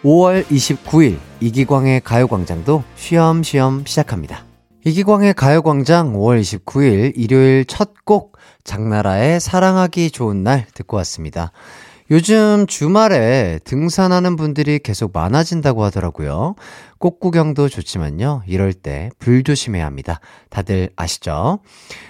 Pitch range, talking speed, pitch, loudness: 100-160 Hz, 270 characters per minute, 130 Hz, -15 LUFS